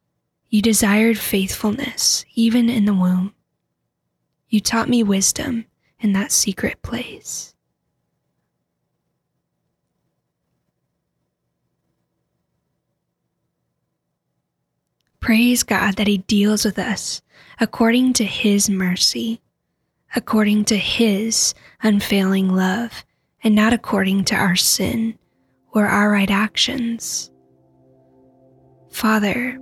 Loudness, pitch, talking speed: -18 LUFS, 205 Hz, 85 wpm